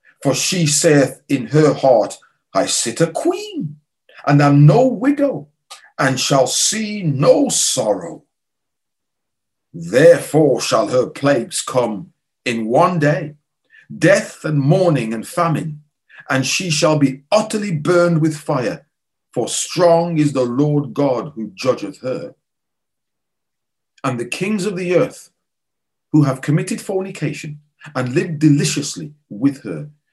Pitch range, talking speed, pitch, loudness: 140-175 Hz, 125 wpm, 150 Hz, -16 LUFS